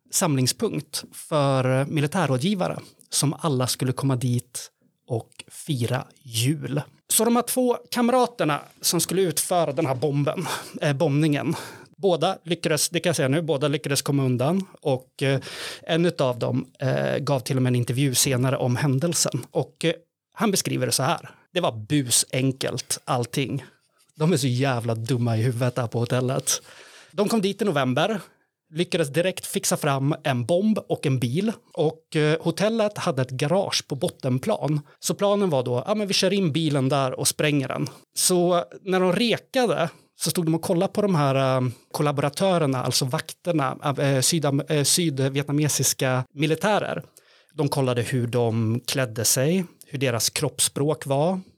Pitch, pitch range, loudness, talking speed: 150 Hz, 130-175 Hz, -23 LUFS, 155 wpm